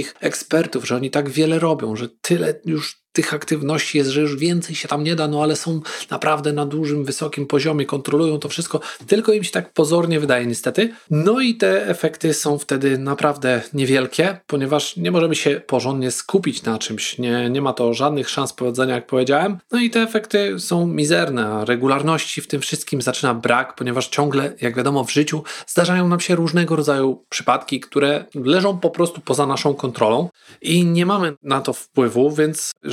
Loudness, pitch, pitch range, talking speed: -19 LUFS, 150 Hz, 135-165 Hz, 185 wpm